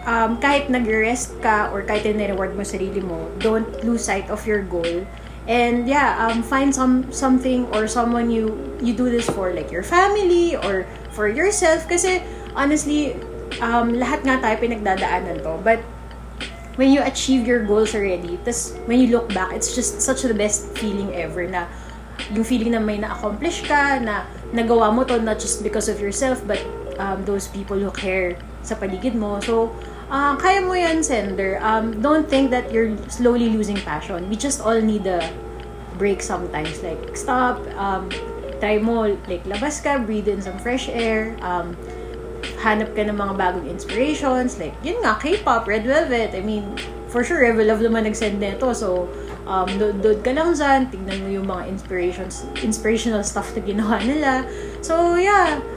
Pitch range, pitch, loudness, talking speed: 200-260 Hz, 225 Hz, -21 LUFS, 175 wpm